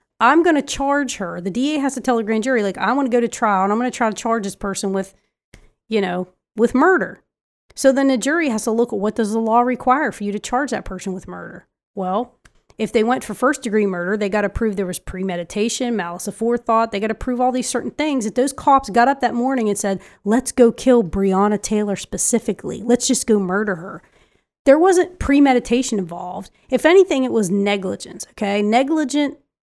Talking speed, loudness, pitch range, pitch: 225 wpm, -19 LUFS, 205-255 Hz, 230 Hz